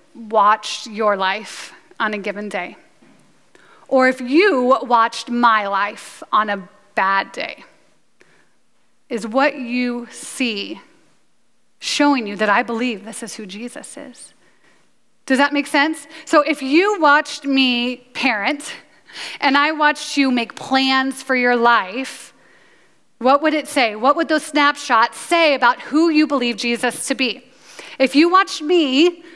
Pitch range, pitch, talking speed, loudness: 230-290 Hz, 260 Hz, 145 wpm, -17 LUFS